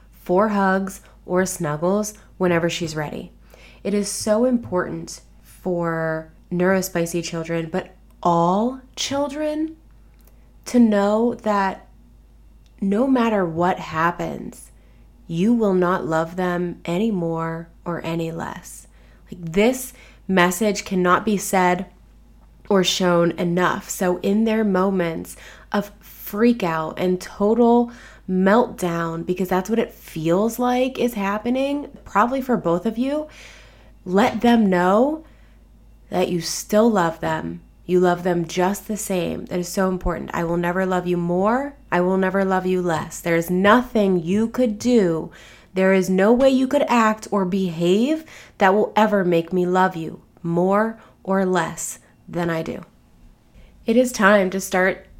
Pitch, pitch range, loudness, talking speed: 190 Hz, 175-215 Hz, -21 LUFS, 140 wpm